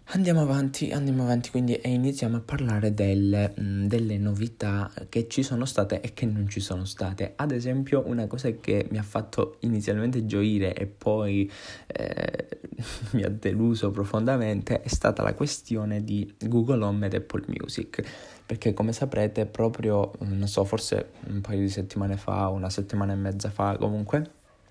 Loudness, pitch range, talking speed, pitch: -28 LUFS, 100-120 Hz, 165 wpm, 105 Hz